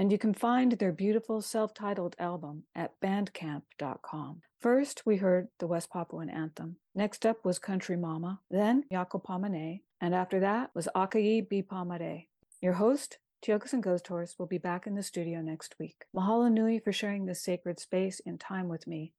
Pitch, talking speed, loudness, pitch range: 185 Hz, 180 wpm, -32 LUFS, 175-210 Hz